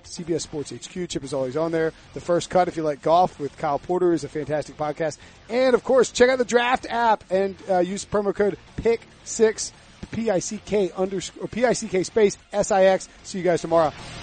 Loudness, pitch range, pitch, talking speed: -23 LUFS, 160-205 Hz, 180 Hz, 240 wpm